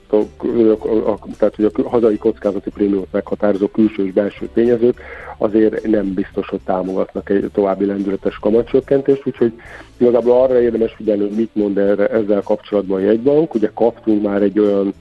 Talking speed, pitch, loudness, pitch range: 170 wpm, 105 Hz, -16 LUFS, 100-115 Hz